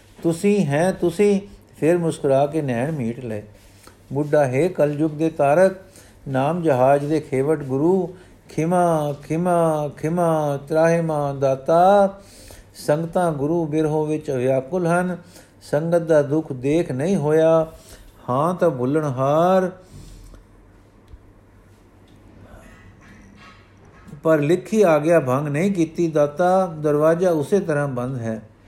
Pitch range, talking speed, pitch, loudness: 115-165 Hz, 115 wpm, 150 Hz, -20 LUFS